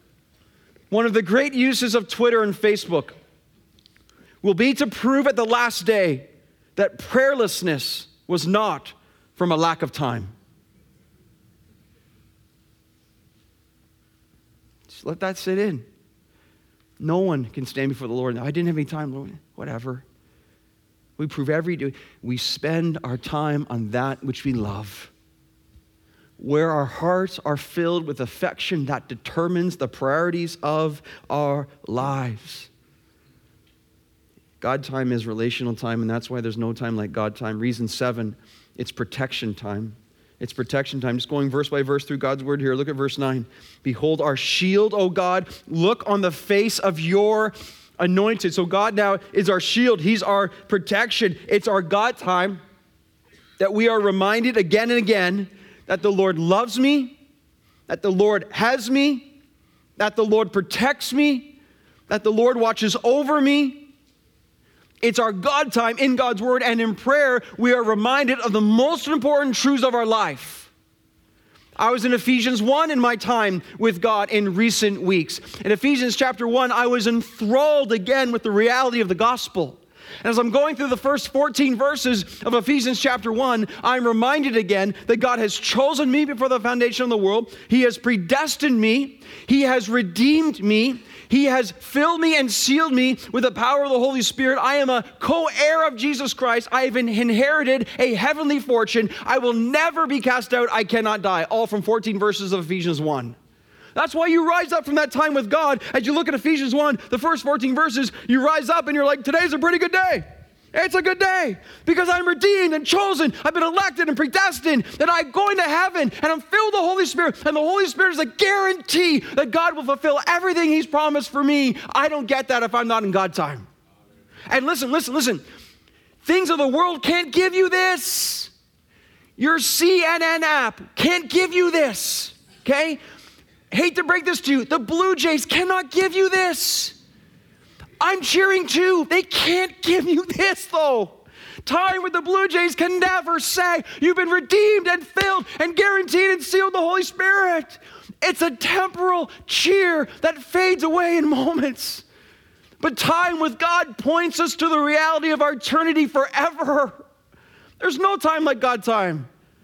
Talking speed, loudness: 175 wpm, -20 LUFS